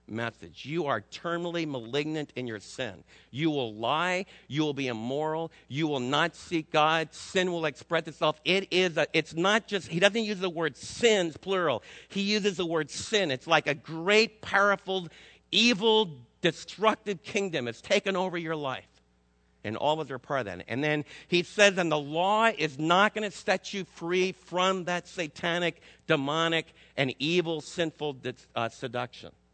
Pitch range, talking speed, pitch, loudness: 140-185 Hz, 175 wpm, 160 Hz, -28 LUFS